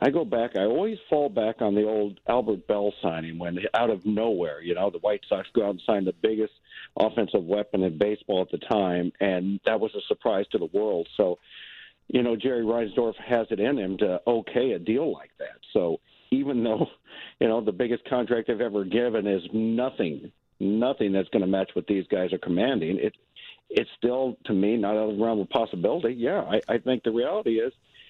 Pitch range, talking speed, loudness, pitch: 100-125 Hz, 215 wpm, -26 LUFS, 110 Hz